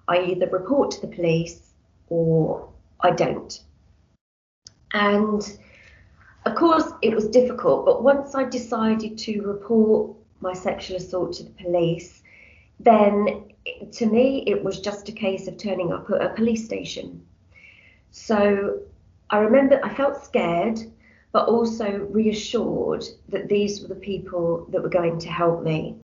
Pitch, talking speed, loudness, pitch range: 200 Hz, 145 wpm, -22 LUFS, 175-225 Hz